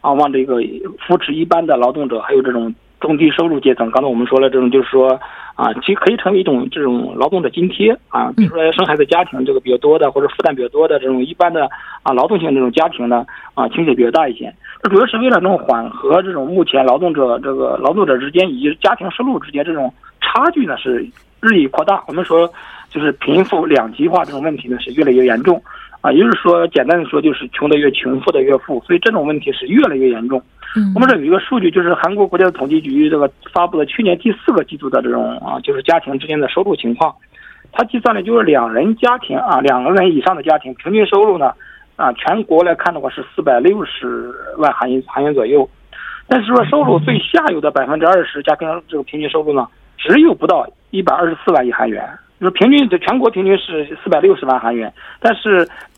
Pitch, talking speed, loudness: 175 Hz, 355 characters per minute, -14 LUFS